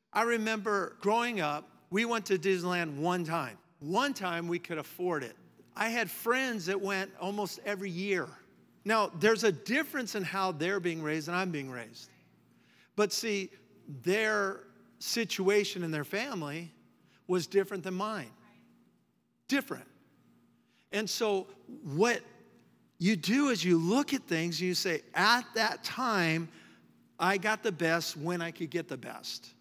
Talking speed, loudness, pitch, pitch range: 150 wpm, -32 LUFS, 190 Hz, 165-215 Hz